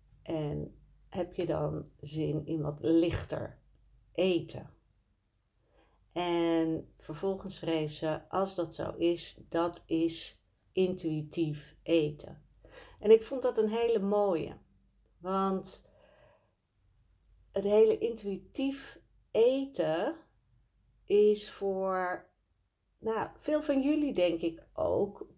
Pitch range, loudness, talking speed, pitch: 150-195 Hz, -32 LUFS, 100 wpm, 170 Hz